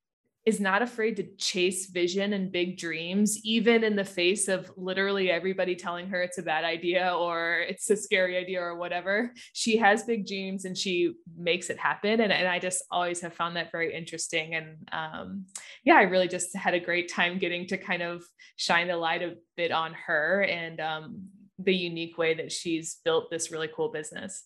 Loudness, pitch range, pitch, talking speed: -28 LUFS, 170-195 Hz, 180 Hz, 200 wpm